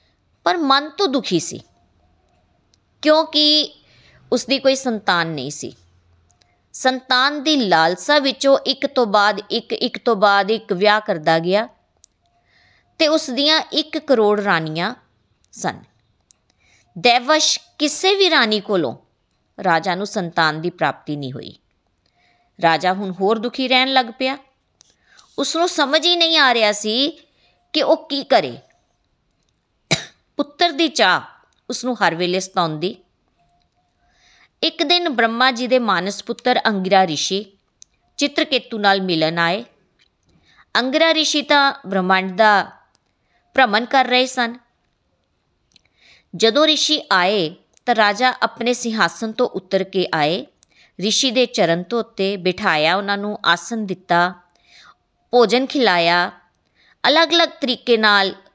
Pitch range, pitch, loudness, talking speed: 185-275 Hz, 225 Hz, -17 LUFS, 125 wpm